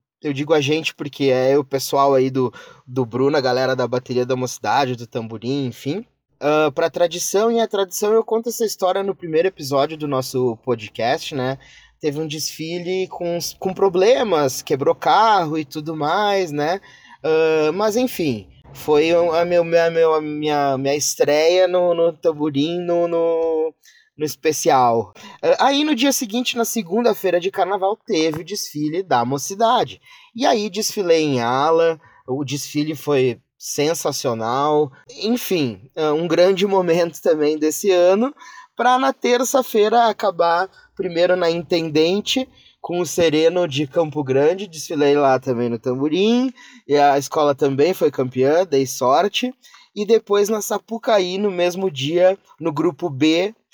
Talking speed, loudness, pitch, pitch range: 150 wpm, -19 LUFS, 165 Hz, 145-195 Hz